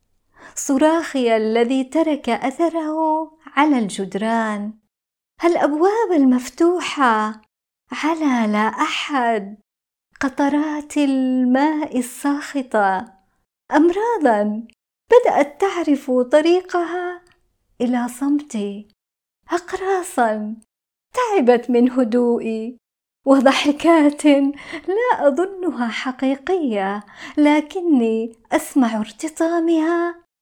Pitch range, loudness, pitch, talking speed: 235-330 Hz, -19 LUFS, 285 Hz, 60 wpm